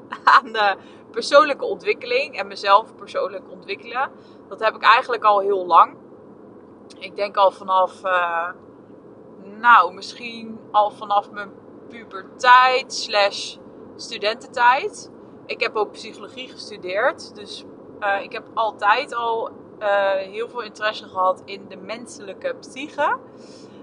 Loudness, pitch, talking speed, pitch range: -20 LUFS, 215 Hz, 115 wpm, 200-250 Hz